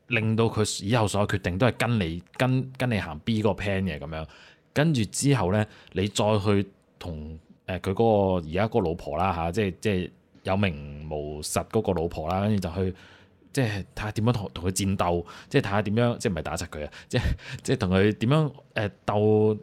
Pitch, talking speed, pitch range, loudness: 100 Hz, 310 characters per minute, 90-110 Hz, -26 LUFS